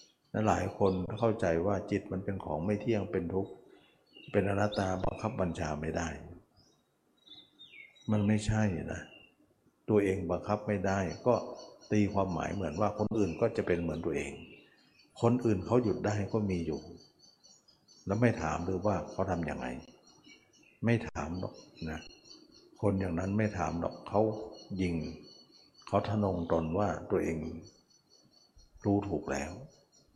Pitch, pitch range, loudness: 95 Hz, 85-105 Hz, -33 LUFS